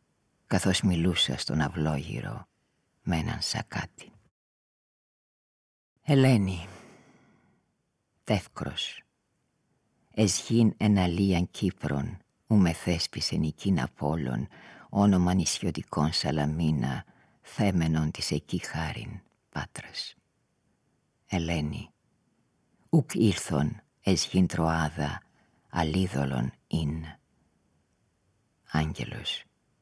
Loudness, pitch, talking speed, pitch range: -28 LUFS, 85 Hz, 65 wpm, 75-95 Hz